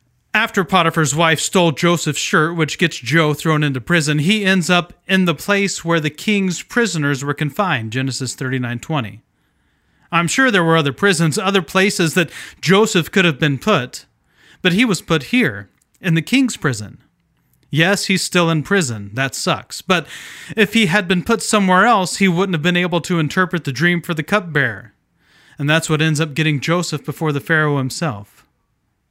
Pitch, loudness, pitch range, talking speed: 165 Hz, -16 LUFS, 150-190 Hz, 180 wpm